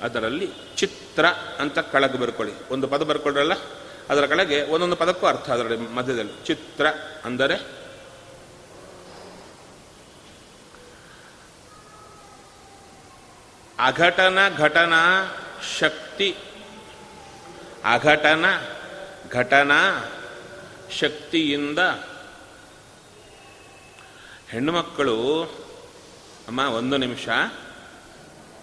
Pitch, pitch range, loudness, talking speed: 145 Hz, 130-165 Hz, -22 LUFS, 60 wpm